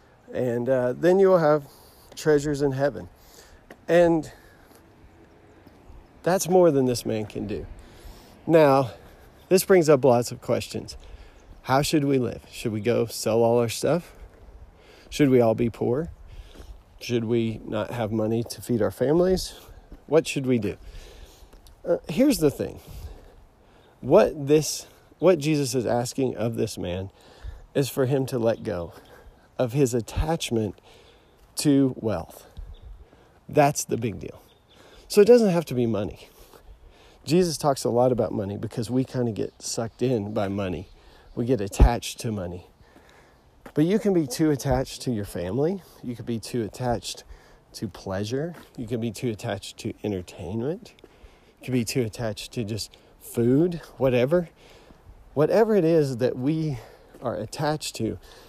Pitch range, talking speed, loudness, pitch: 105-145 Hz, 150 wpm, -24 LUFS, 120 Hz